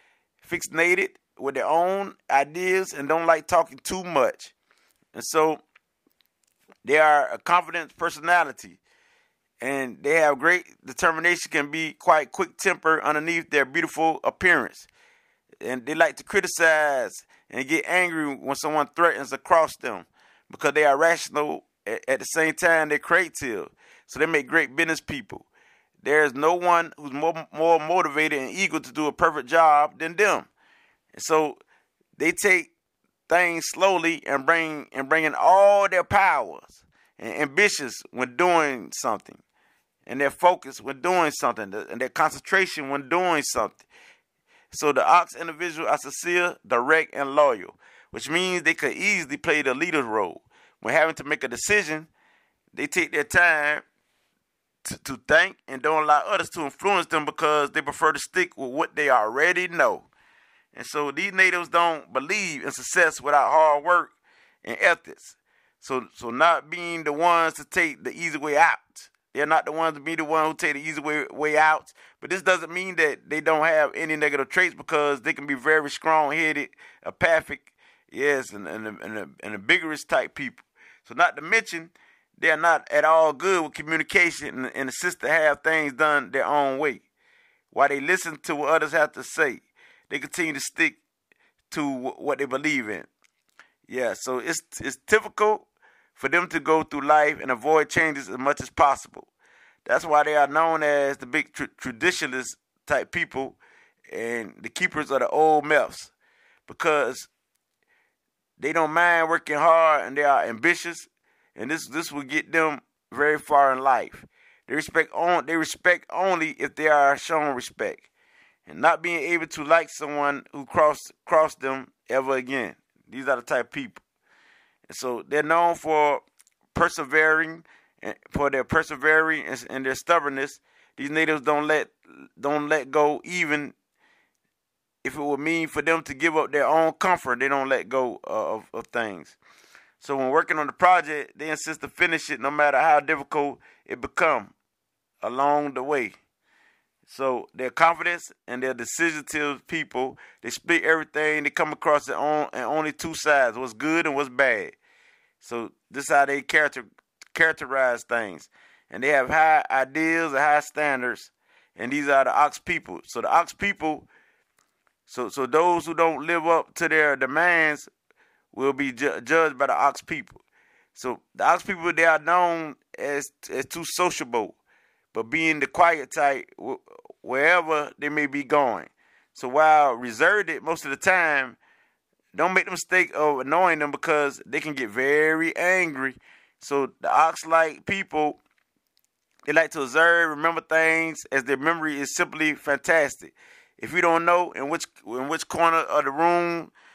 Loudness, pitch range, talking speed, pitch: -23 LUFS, 145-170 Hz, 165 wpm, 155 Hz